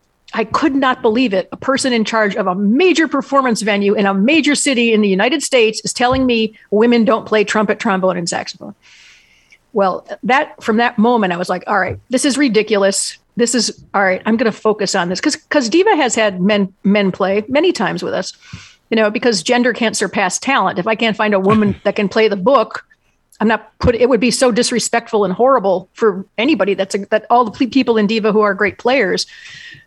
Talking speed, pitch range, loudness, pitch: 220 wpm, 205-255 Hz, -15 LUFS, 220 Hz